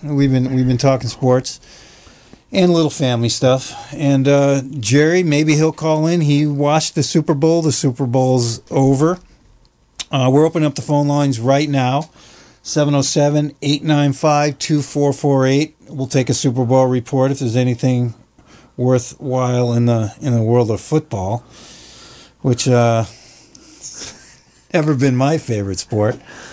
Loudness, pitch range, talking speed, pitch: -16 LUFS, 125-150 Hz, 140 wpm, 135 Hz